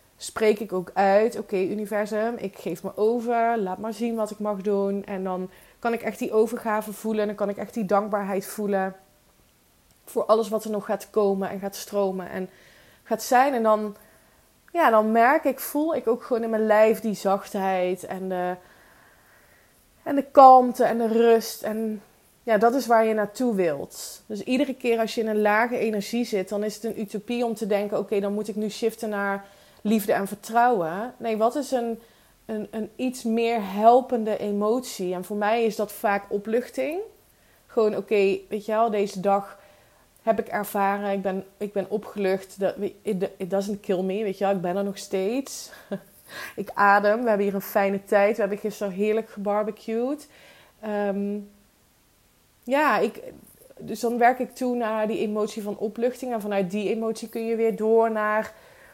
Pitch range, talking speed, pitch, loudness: 200-230 Hz, 190 wpm, 215 Hz, -24 LUFS